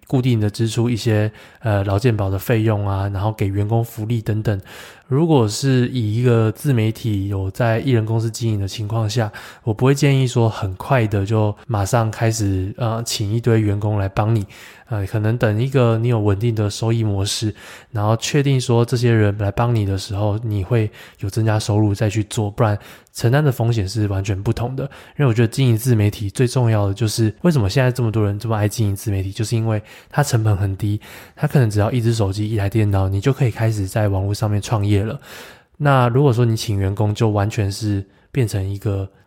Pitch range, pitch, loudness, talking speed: 105-120 Hz, 110 Hz, -19 LUFS, 315 characters per minute